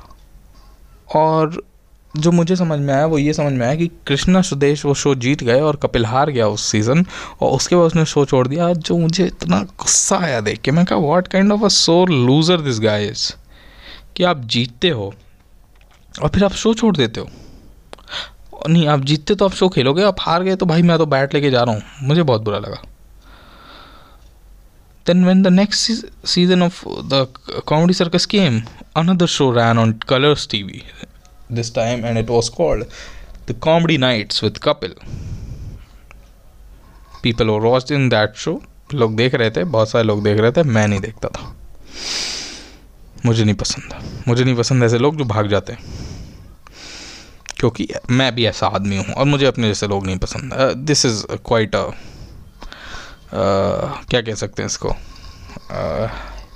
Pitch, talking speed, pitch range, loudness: 130 Hz, 155 wpm, 110-165 Hz, -16 LUFS